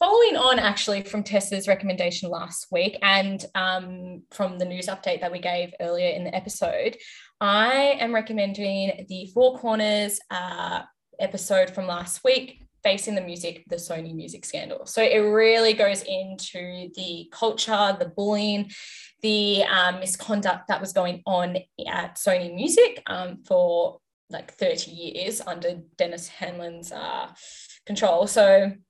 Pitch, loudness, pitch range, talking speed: 195 Hz, -24 LUFS, 180-225 Hz, 145 wpm